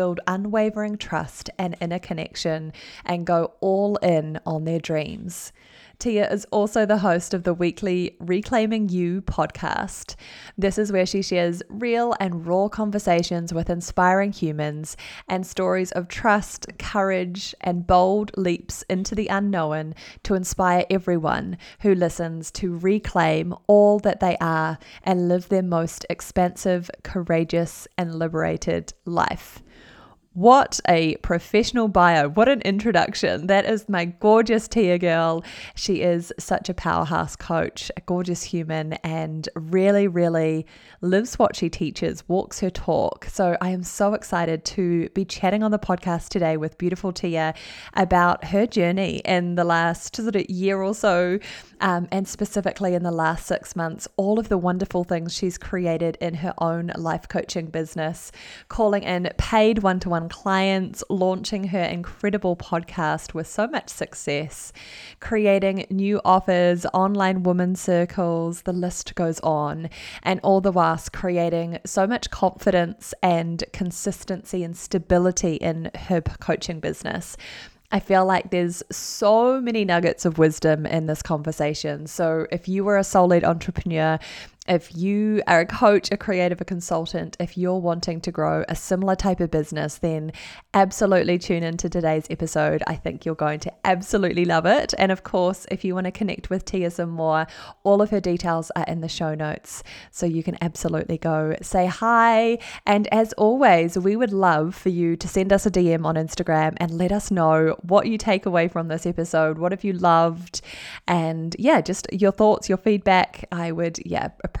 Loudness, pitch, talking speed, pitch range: -22 LUFS, 180 Hz, 160 wpm, 165-195 Hz